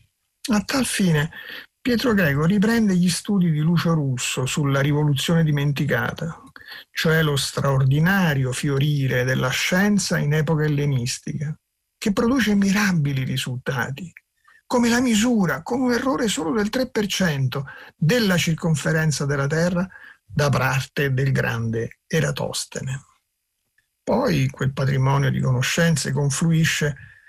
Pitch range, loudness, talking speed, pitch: 140-190 Hz, -21 LUFS, 110 wpm, 155 Hz